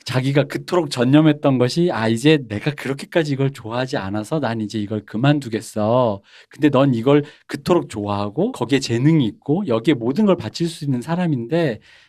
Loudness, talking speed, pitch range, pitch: -19 LUFS, 375 characters per minute, 115-155 Hz, 135 Hz